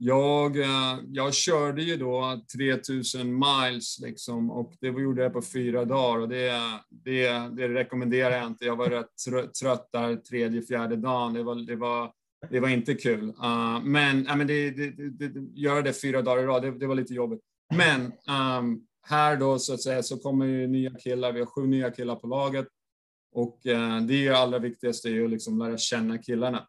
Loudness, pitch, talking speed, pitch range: -27 LUFS, 125 Hz, 200 wpm, 120-135 Hz